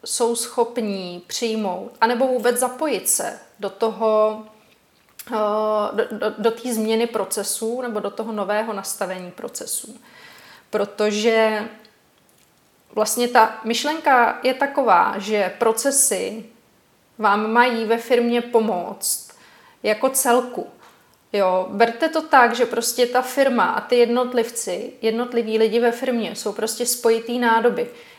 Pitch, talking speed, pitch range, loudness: 230 Hz, 115 wpm, 215-245 Hz, -20 LUFS